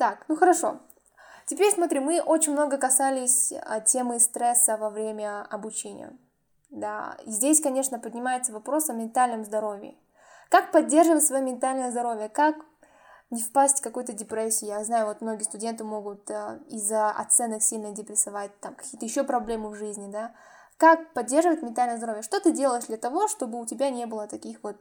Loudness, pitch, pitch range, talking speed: -25 LUFS, 240 Hz, 215-280 Hz, 160 wpm